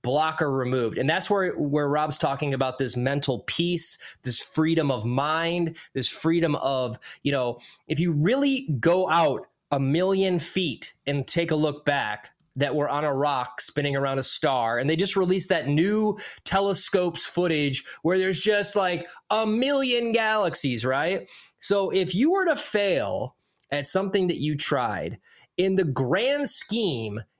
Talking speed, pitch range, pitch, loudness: 160 wpm, 140-190 Hz, 165 Hz, -25 LUFS